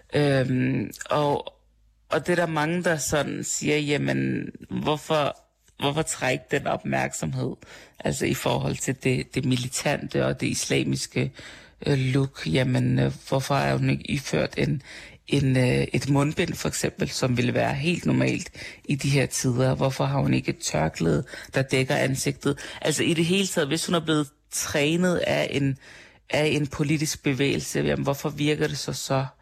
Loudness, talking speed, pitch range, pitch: -25 LUFS, 165 wpm, 130-150 Hz, 140 Hz